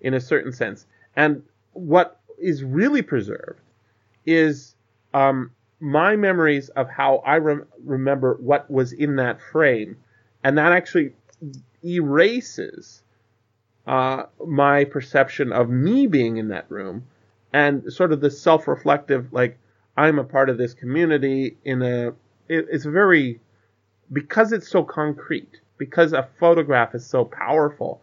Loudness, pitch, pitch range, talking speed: -20 LUFS, 135 Hz, 120-155 Hz, 135 wpm